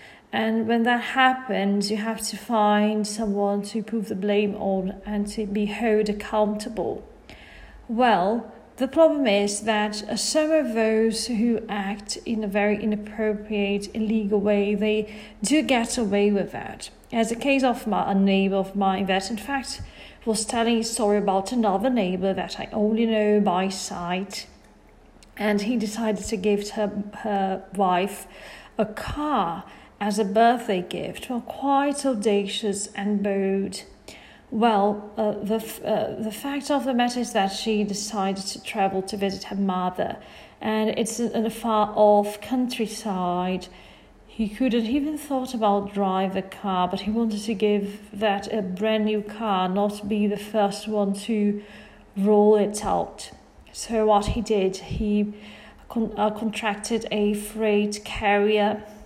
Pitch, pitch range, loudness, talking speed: 210 Hz, 205-225 Hz, -24 LUFS, 150 wpm